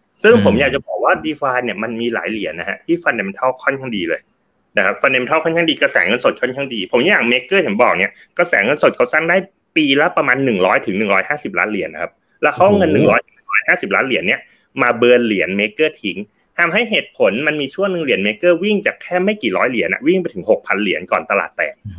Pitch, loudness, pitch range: 155 Hz, -16 LUFS, 125-200 Hz